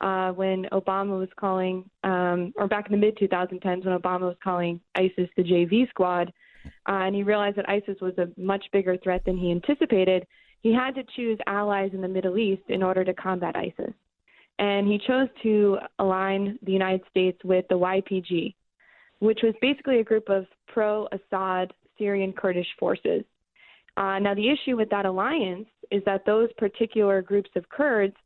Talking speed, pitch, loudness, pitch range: 180 wpm, 195 Hz, -25 LUFS, 185-210 Hz